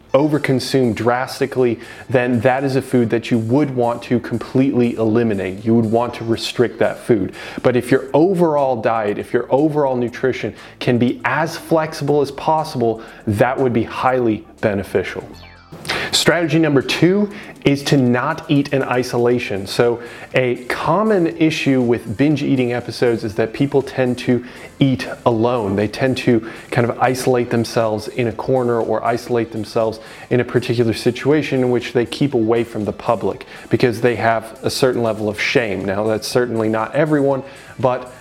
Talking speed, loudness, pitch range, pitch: 165 wpm, -18 LUFS, 115-135 Hz, 125 Hz